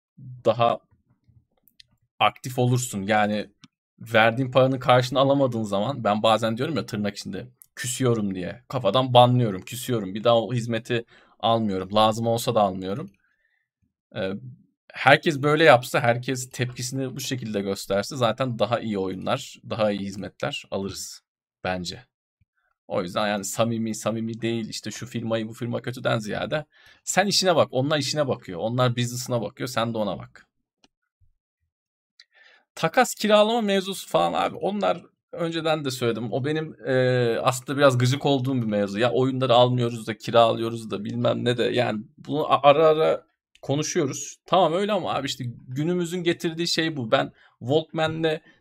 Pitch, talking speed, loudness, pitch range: 120 Hz, 140 wpm, -24 LUFS, 110-135 Hz